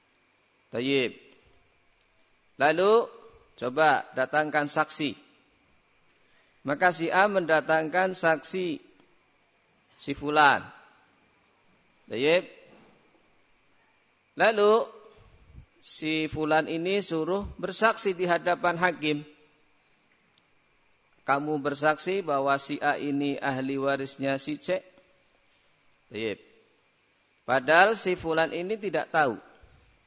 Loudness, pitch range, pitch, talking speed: -26 LUFS, 145-190 Hz, 160 Hz, 80 wpm